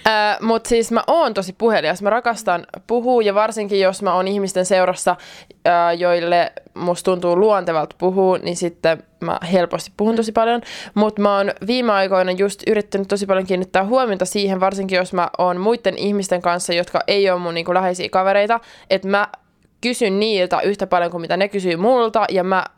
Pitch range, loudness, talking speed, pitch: 180-210 Hz, -18 LUFS, 180 wpm, 195 Hz